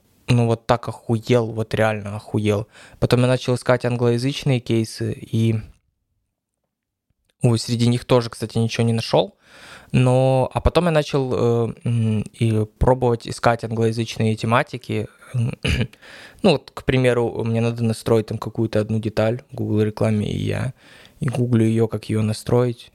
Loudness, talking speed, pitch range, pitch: -21 LUFS, 140 wpm, 110-125 Hz, 115 Hz